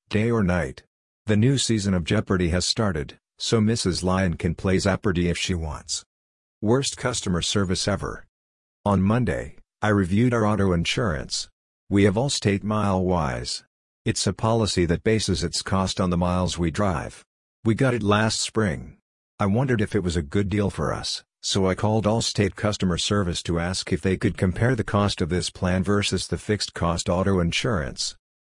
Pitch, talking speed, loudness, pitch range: 95 Hz, 175 wpm, -24 LUFS, 90-105 Hz